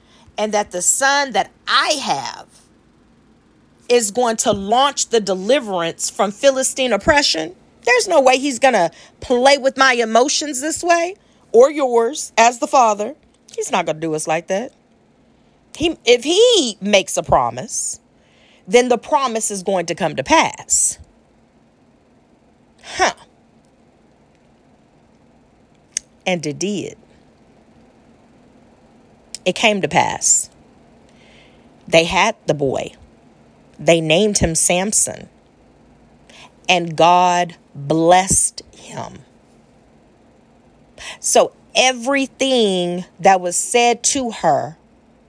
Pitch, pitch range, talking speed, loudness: 230 Hz, 185-270 Hz, 110 wpm, -16 LUFS